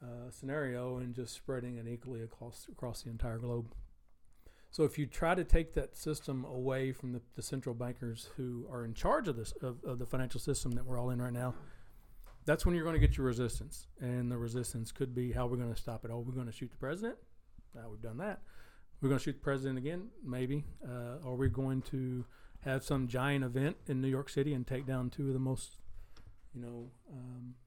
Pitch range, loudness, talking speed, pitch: 120-135 Hz, -38 LUFS, 230 wpm, 125 Hz